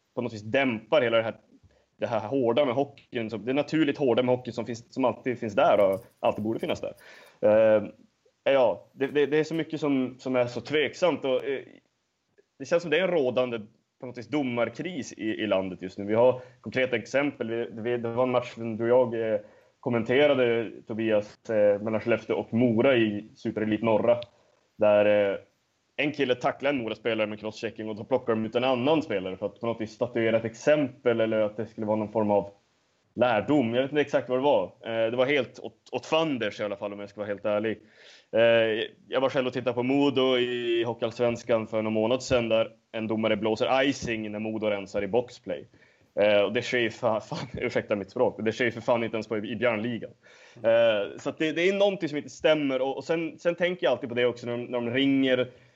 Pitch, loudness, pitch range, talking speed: 120 Hz, -27 LUFS, 110-130 Hz, 210 wpm